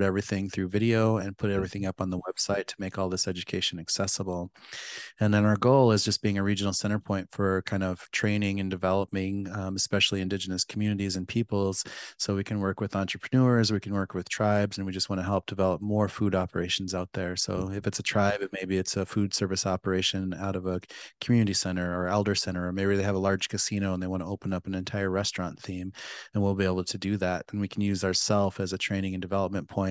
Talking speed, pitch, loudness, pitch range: 235 wpm, 95 Hz, -28 LUFS, 95-100 Hz